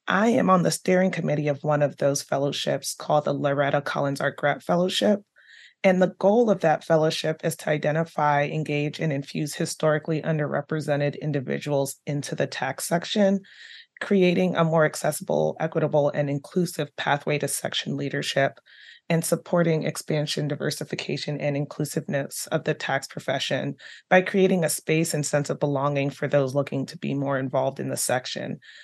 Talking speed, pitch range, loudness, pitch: 160 wpm, 145-170 Hz, -24 LUFS, 155 Hz